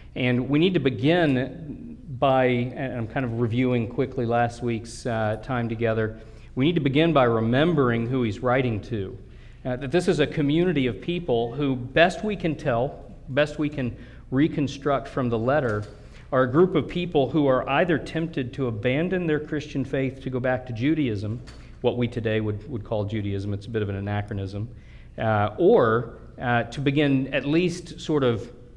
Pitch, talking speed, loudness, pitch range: 130 Hz, 185 wpm, -24 LUFS, 115-150 Hz